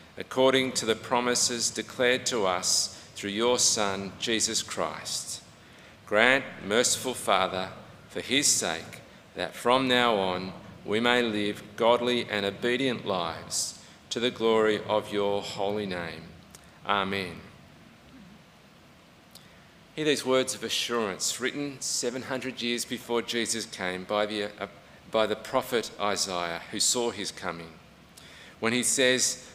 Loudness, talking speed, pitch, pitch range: -27 LUFS, 125 wpm, 110 Hz, 100-125 Hz